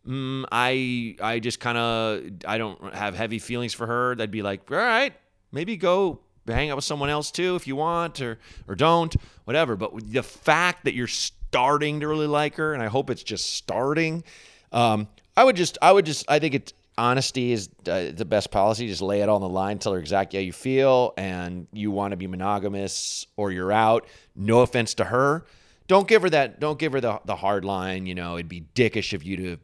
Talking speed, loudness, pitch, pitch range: 225 wpm, -24 LUFS, 120 Hz, 100-145 Hz